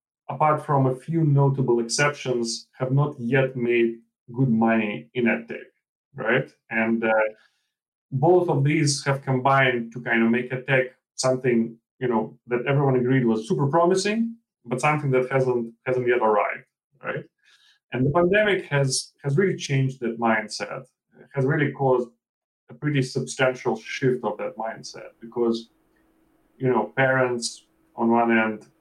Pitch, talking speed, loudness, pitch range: 130 Hz, 150 wpm, -23 LUFS, 115-140 Hz